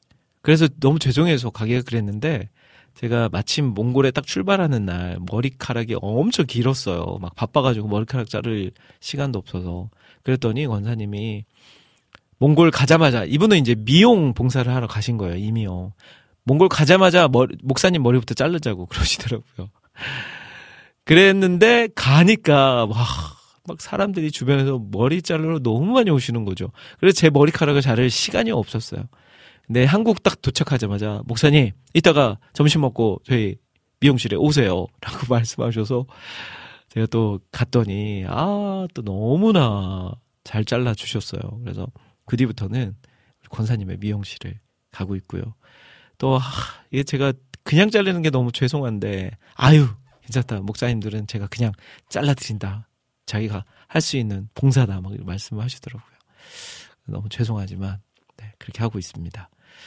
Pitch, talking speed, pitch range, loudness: 120 Hz, 320 characters per minute, 105-140 Hz, -20 LUFS